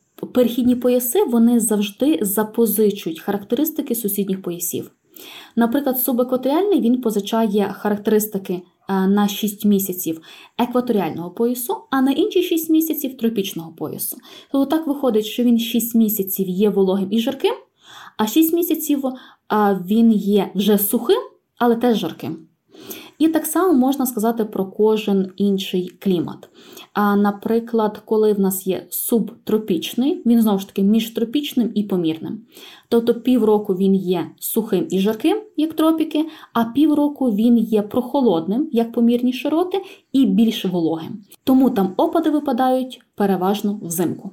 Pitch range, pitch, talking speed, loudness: 200-275 Hz, 230 Hz, 130 wpm, -19 LUFS